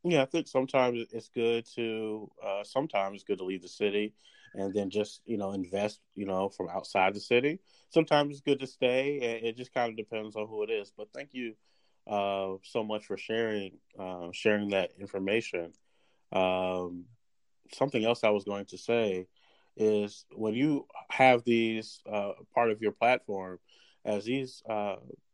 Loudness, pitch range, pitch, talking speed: -31 LUFS, 100-120 Hz, 105 Hz, 180 wpm